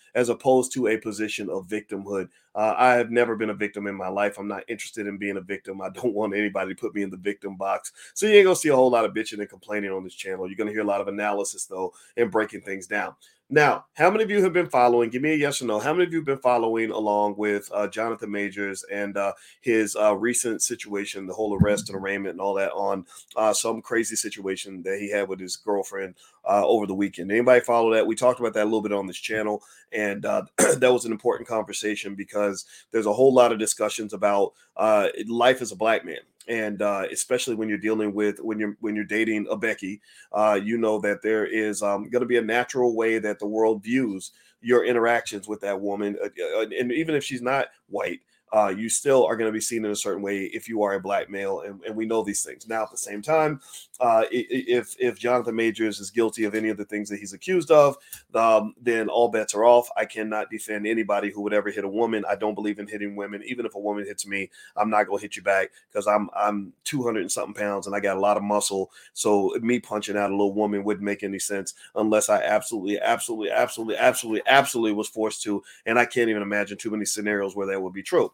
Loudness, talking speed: -24 LUFS, 245 wpm